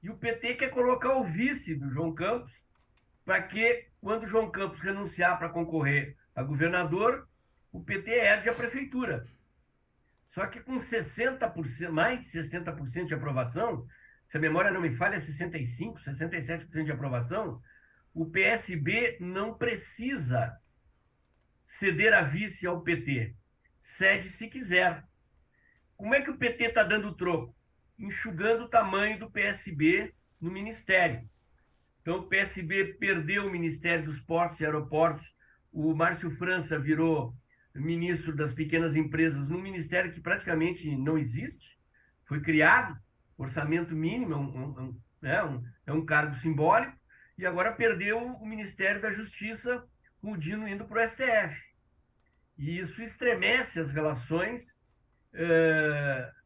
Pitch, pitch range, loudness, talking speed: 170 Hz, 155-215 Hz, -29 LUFS, 135 wpm